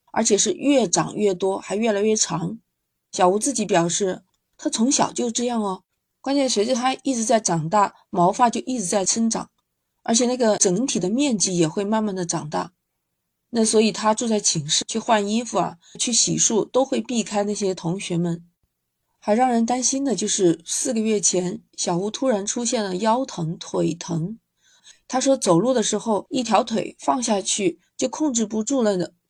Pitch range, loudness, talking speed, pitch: 185-245 Hz, -21 LUFS, 260 characters per minute, 210 Hz